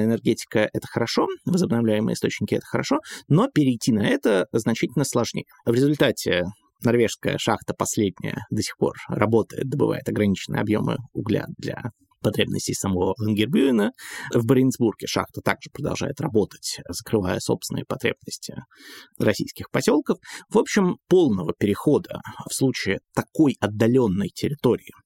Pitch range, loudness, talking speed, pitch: 105-130 Hz, -23 LUFS, 120 wpm, 115 Hz